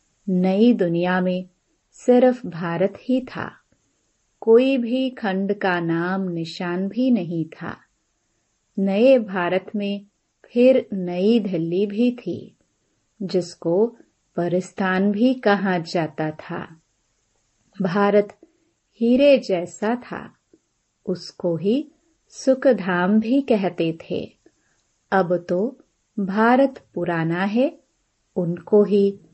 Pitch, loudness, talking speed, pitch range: 195 Hz, -21 LUFS, 95 wpm, 175-235 Hz